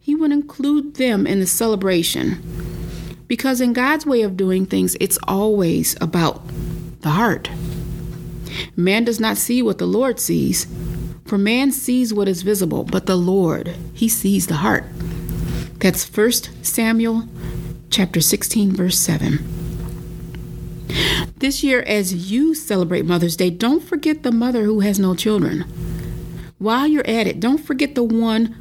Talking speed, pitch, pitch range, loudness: 145 wpm, 190 Hz, 165-230 Hz, -18 LUFS